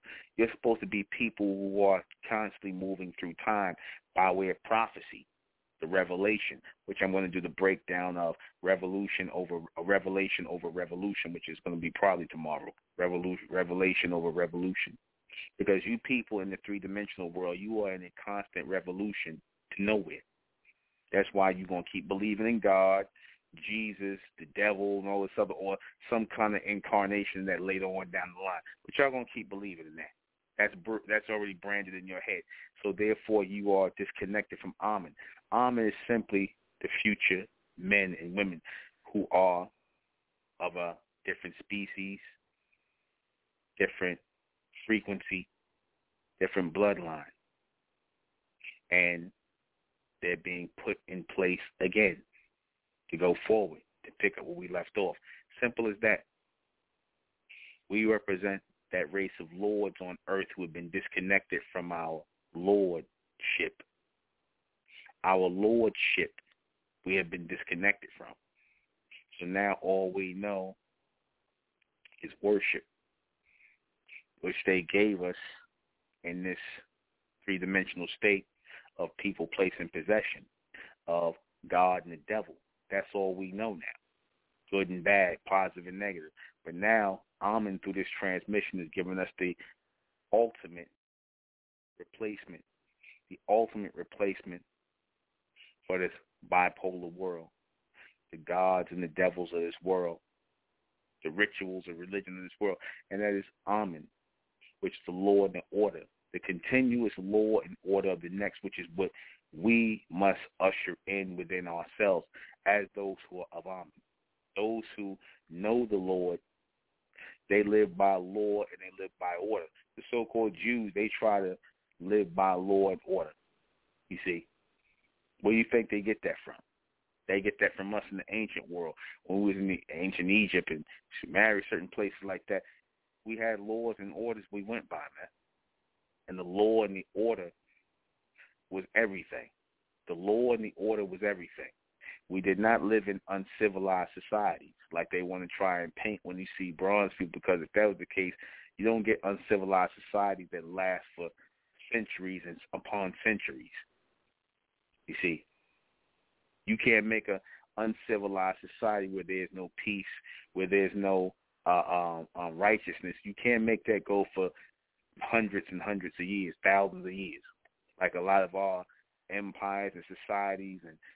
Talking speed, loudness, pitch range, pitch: 150 wpm, -32 LUFS, 90-105 Hz, 95 Hz